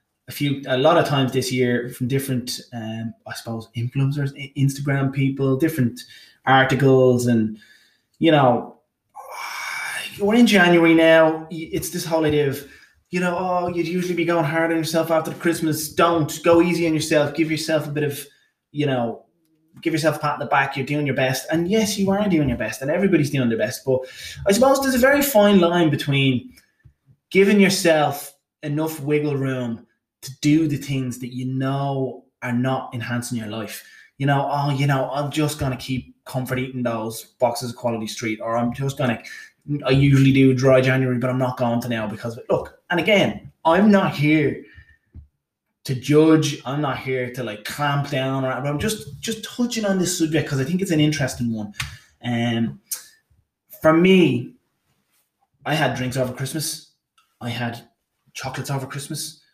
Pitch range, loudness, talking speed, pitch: 130-160 Hz, -20 LUFS, 185 wpm, 140 Hz